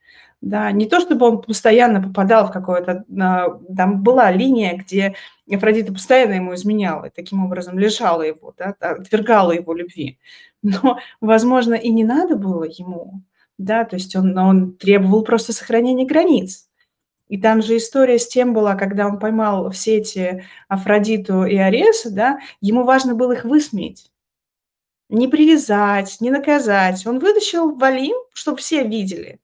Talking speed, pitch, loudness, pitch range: 150 wpm, 215 Hz, -16 LUFS, 190-250 Hz